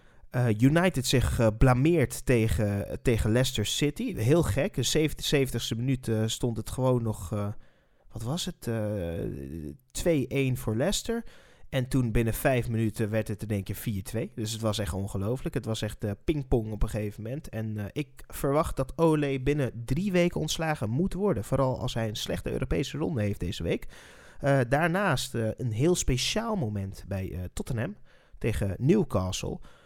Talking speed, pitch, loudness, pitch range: 175 wpm, 120 Hz, -28 LUFS, 110-140 Hz